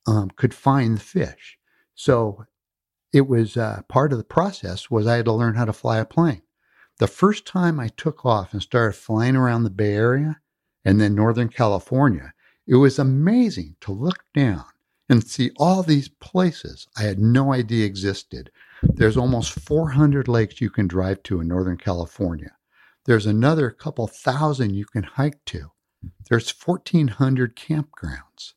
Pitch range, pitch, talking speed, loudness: 105-145 Hz, 120 Hz, 165 wpm, -21 LUFS